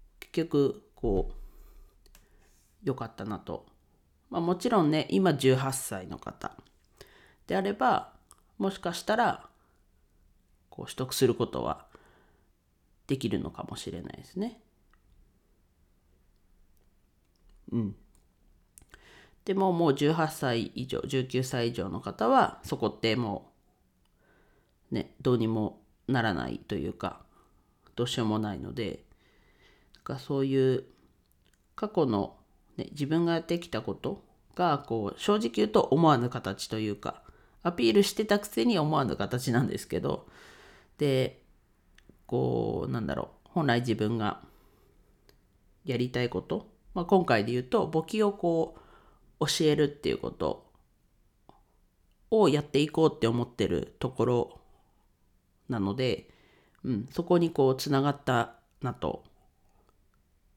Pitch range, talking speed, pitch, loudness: 100-155 Hz, 225 characters per minute, 125 Hz, -29 LUFS